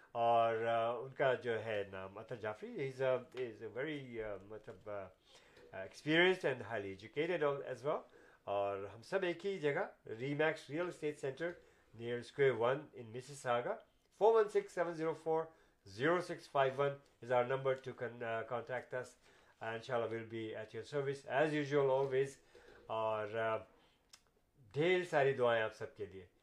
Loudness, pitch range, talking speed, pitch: -38 LUFS, 115-155 Hz, 150 wpm, 130 Hz